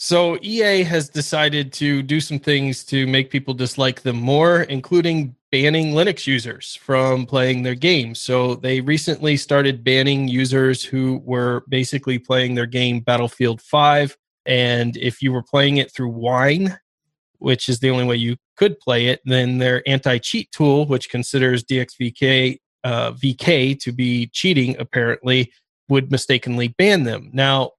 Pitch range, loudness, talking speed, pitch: 125-145 Hz, -18 LUFS, 155 wpm, 130 Hz